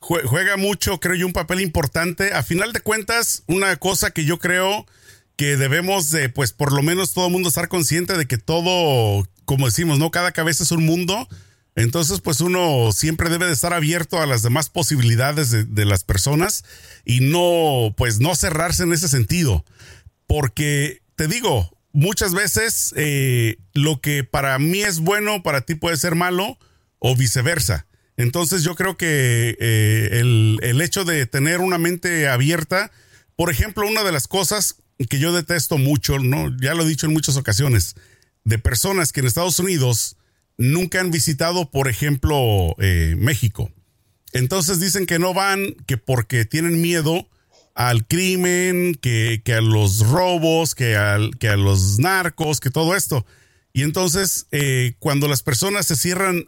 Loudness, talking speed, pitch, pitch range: -19 LUFS, 170 wpm, 150 Hz, 120-175 Hz